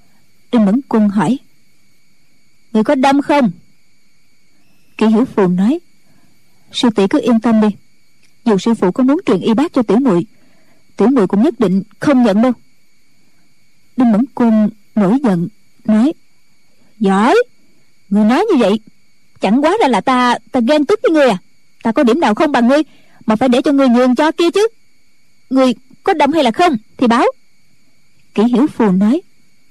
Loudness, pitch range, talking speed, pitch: -13 LUFS, 215-280 Hz, 180 wpm, 240 Hz